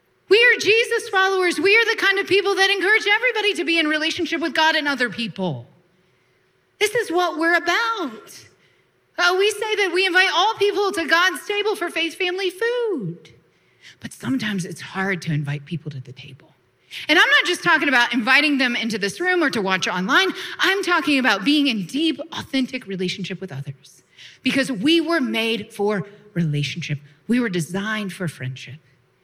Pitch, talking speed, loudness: 285 Hz, 180 wpm, -19 LUFS